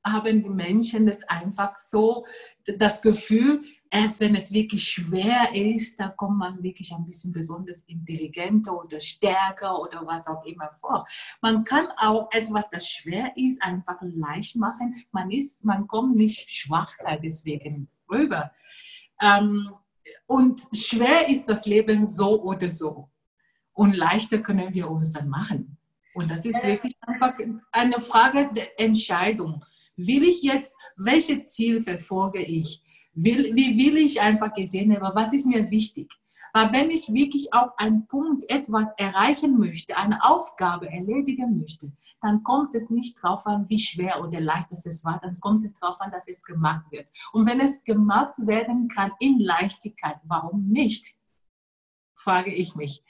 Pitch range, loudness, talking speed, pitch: 175-230 Hz, -23 LUFS, 155 wpm, 210 Hz